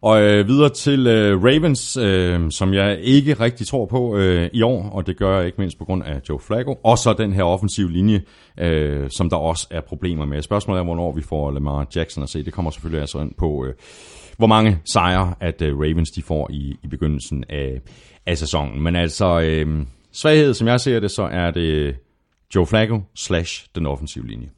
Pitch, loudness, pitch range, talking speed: 90 Hz, -19 LUFS, 75-105 Hz, 210 wpm